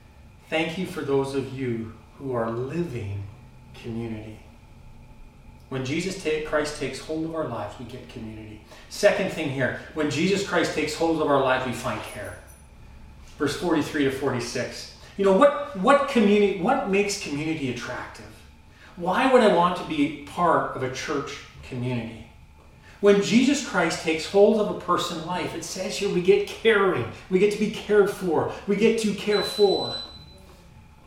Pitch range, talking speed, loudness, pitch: 120-190 Hz, 165 wpm, -24 LUFS, 145 Hz